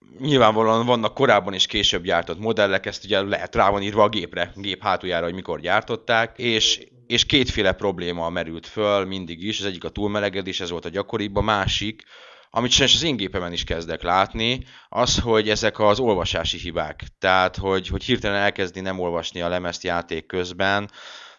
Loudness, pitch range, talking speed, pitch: -22 LUFS, 90-110 Hz, 180 wpm, 100 Hz